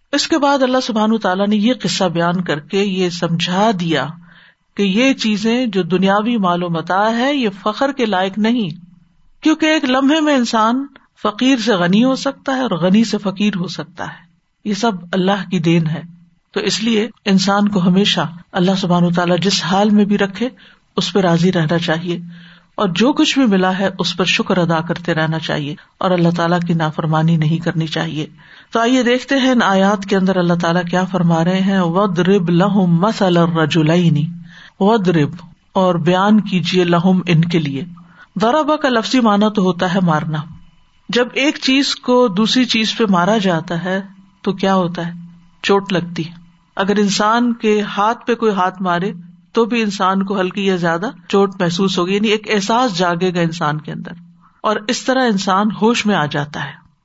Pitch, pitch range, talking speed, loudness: 190 Hz, 175-220 Hz, 185 wpm, -16 LUFS